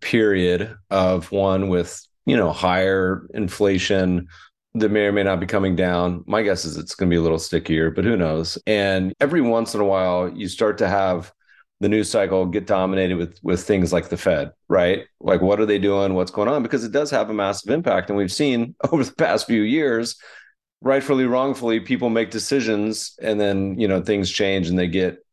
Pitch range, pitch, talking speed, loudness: 90-110 Hz, 95 Hz, 210 wpm, -21 LUFS